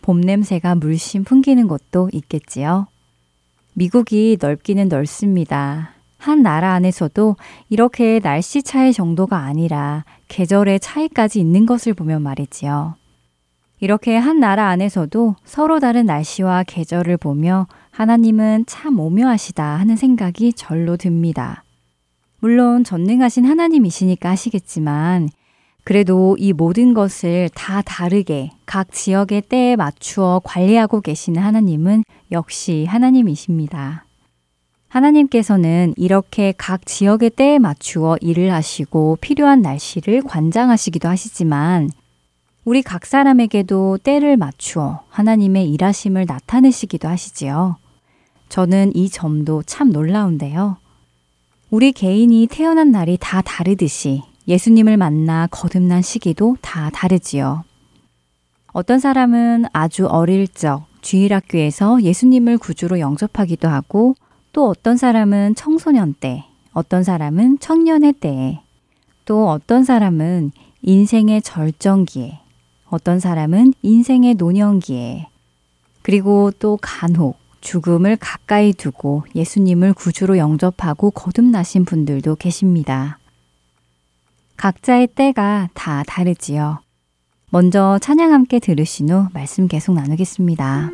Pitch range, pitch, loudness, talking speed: 155-220 Hz, 185 Hz, -15 LUFS, 275 characters per minute